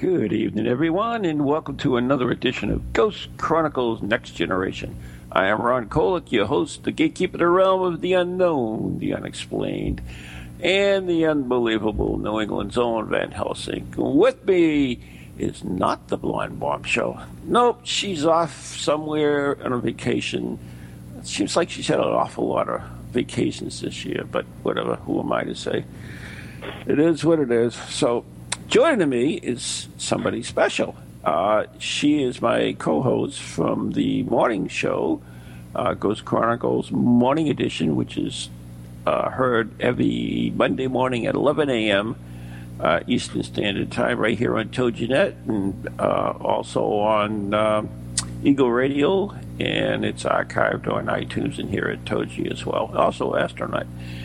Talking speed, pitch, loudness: 150 wpm, 115 Hz, -22 LUFS